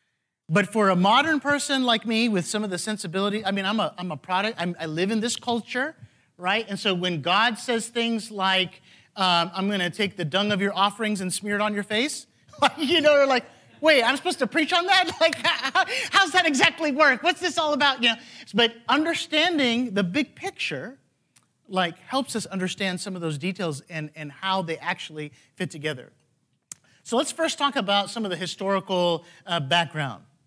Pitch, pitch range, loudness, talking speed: 205 Hz, 175-270 Hz, -23 LUFS, 200 wpm